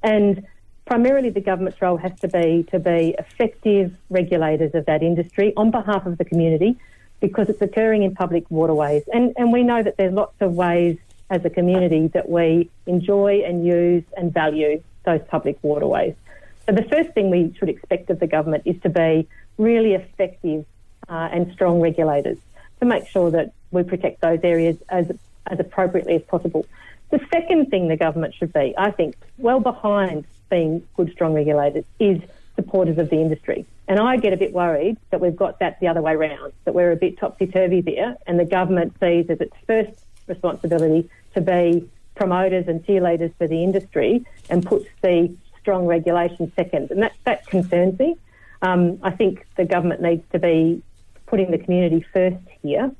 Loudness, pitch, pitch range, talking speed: -20 LUFS, 180 Hz, 170-200 Hz, 180 wpm